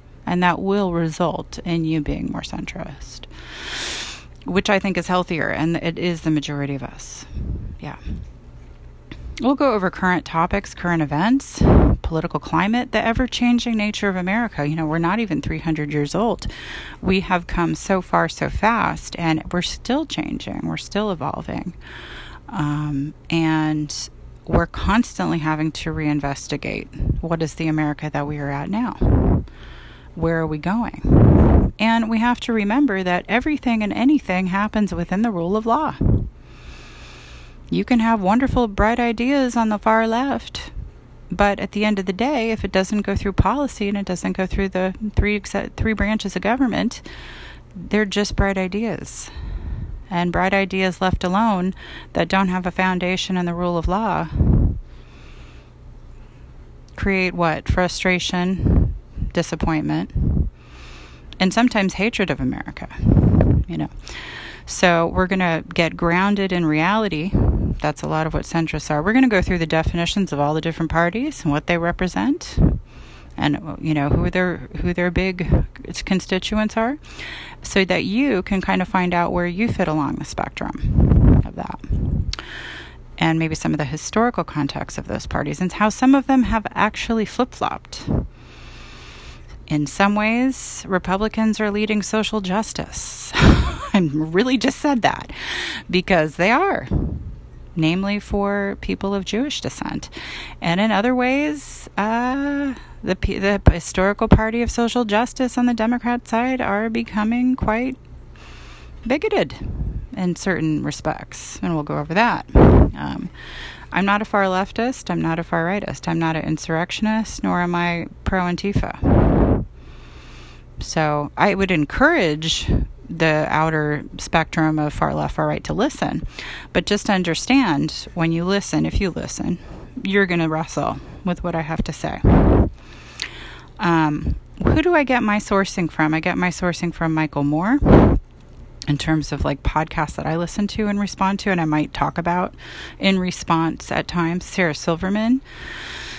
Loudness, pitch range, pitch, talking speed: -20 LUFS, 160-215 Hz, 185 Hz, 155 wpm